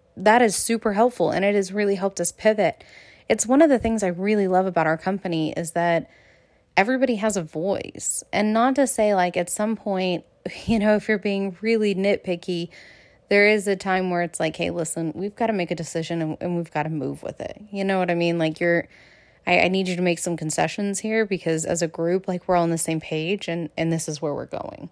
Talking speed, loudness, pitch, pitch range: 240 wpm, -22 LUFS, 185 Hz, 170-210 Hz